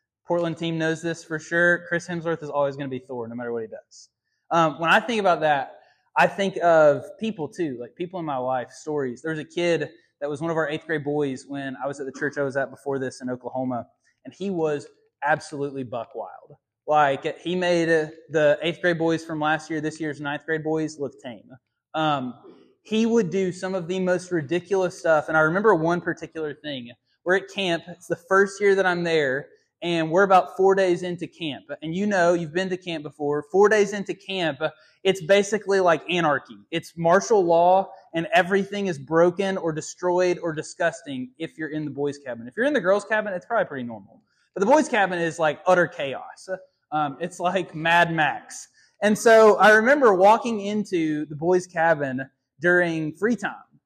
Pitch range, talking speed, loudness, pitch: 150-185 Hz, 205 wpm, -23 LUFS, 165 Hz